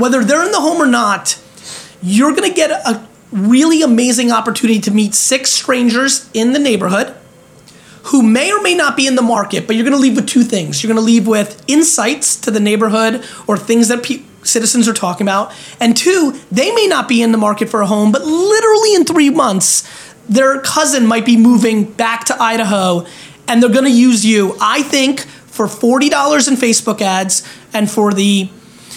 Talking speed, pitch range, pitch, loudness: 195 wpm, 215-275 Hz, 235 Hz, -12 LUFS